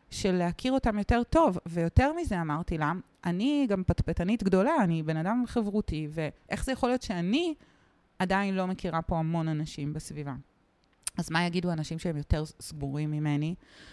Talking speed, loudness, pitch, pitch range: 160 wpm, -30 LUFS, 175 Hz, 155-210 Hz